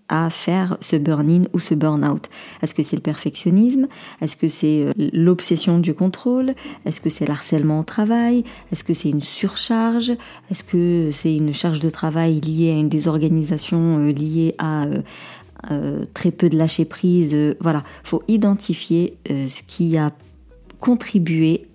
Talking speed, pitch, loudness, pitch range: 160 wpm, 165 Hz, -20 LUFS, 155-185 Hz